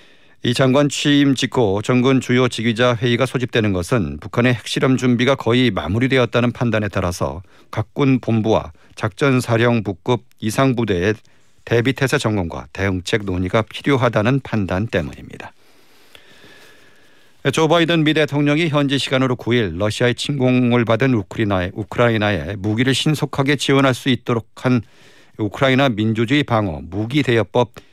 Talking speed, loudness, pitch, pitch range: 335 characters per minute, -18 LUFS, 120 Hz, 110-135 Hz